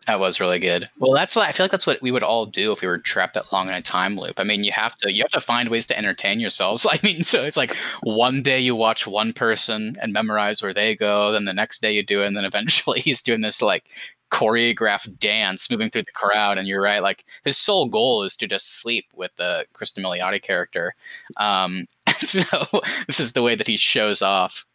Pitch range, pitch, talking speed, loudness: 105-125 Hz, 110 Hz, 245 wpm, -19 LUFS